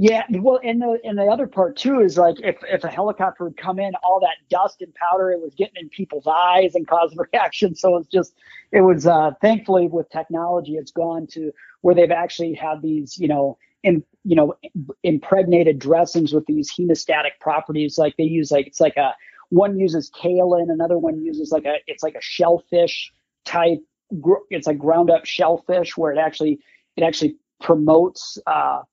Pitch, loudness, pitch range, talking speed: 170 Hz, -19 LUFS, 155-185 Hz, 195 wpm